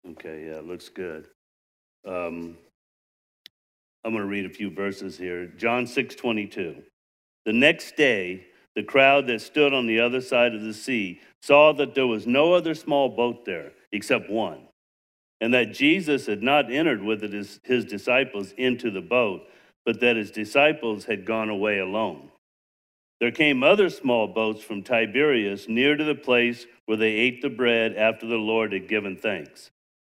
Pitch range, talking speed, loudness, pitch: 95-125 Hz, 165 wpm, -23 LUFS, 110 Hz